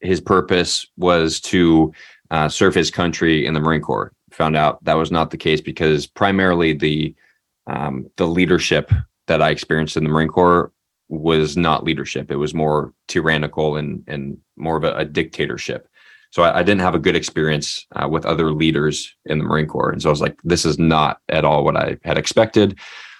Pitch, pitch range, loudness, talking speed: 80 Hz, 75-85 Hz, -18 LUFS, 195 wpm